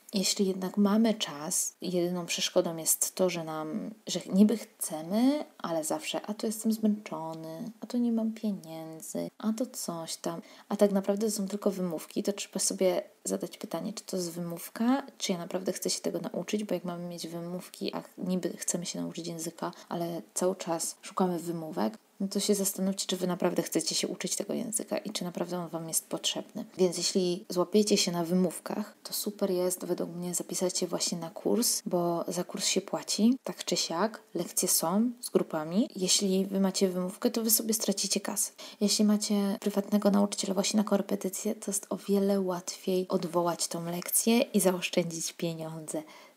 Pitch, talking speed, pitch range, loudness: 190 Hz, 180 wpm, 175-210 Hz, -30 LUFS